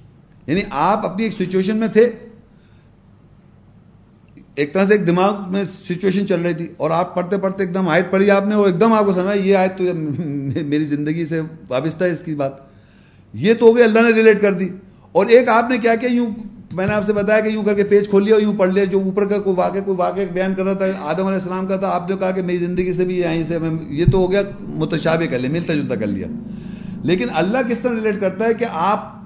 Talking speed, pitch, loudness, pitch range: 250 wpm, 190 Hz, -18 LUFS, 175-210 Hz